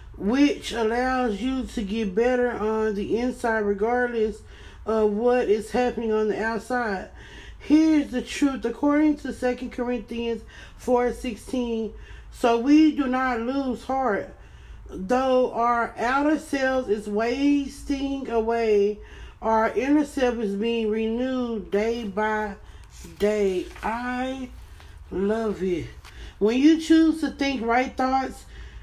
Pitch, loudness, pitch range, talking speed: 240 Hz, -24 LUFS, 215-260 Hz, 120 wpm